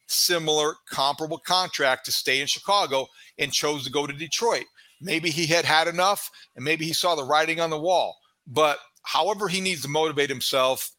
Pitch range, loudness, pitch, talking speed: 145-175 Hz, -24 LUFS, 160 Hz, 185 wpm